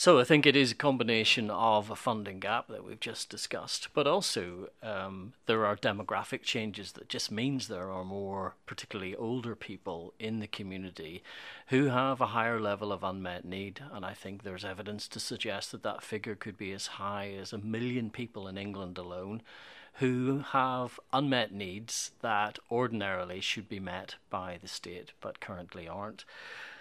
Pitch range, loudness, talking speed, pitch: 95-120 Hz, -33 LUFS, 175 wpm, 105 Hz